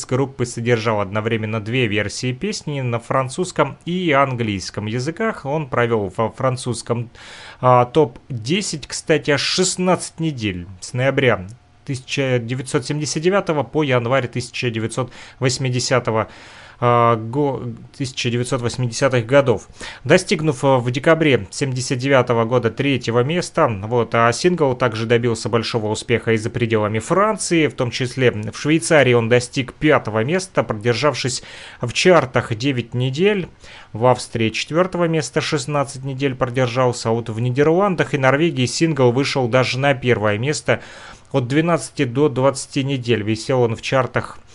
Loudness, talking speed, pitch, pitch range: -19 LUFS, 120 wpm, 130 Hz, 120-145 Hz